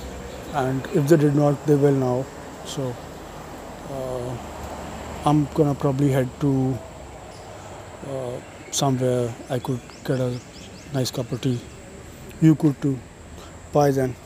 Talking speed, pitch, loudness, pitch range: 125 wpm, 130 Hz, -23 LUFS, 95-140 Hz